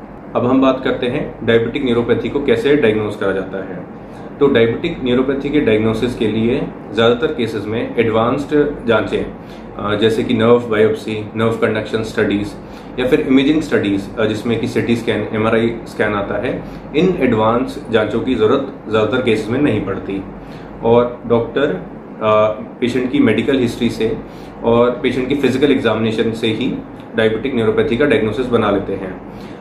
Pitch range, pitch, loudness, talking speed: 110-125 Hz, 115 Hz, -16 LUFS, 150 wpm